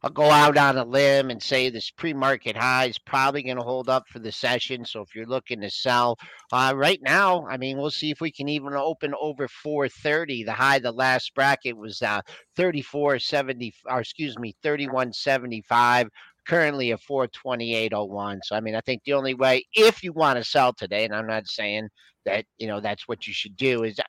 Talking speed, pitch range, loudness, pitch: 220 wpm, 120-140 Hz, -24 LUFS, 130 Hz